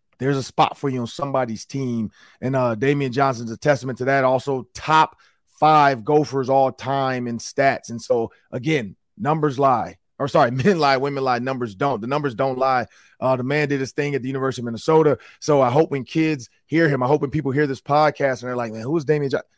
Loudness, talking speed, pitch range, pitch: -21 LUFS, 225 wpm, 125-145 Hz, 135 Hz